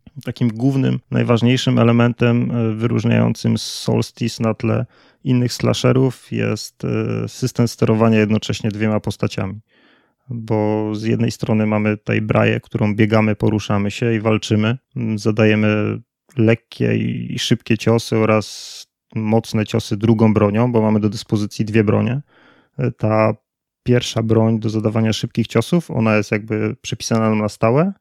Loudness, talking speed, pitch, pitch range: -18 LUFS, 125 wpm, 110 Hz, 110-120 Hz